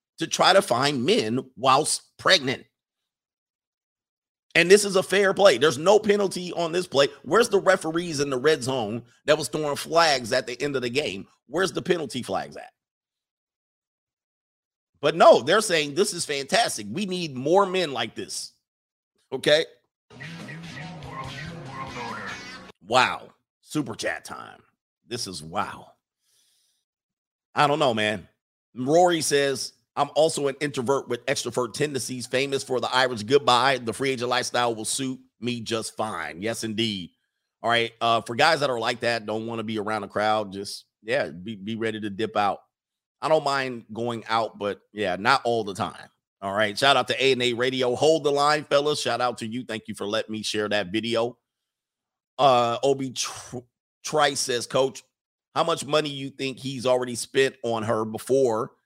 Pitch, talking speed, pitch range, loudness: 130 Hz, 170 wpm, 115-150 Hz, -24 LUFS